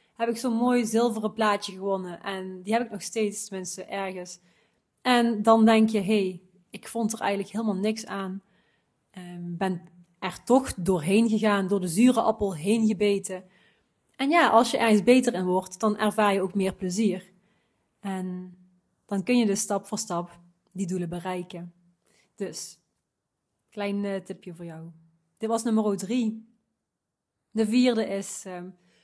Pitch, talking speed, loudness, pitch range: 200 Hz, 165 wpm, -25 LUFS, 185-220 Hz